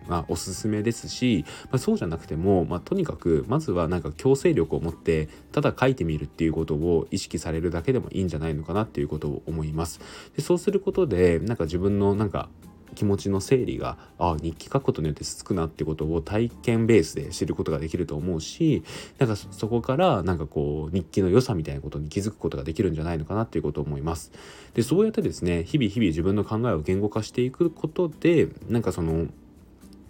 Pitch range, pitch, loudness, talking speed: 80-115 Hz, 90 Hz, -26 LUFS, 455 characters per minute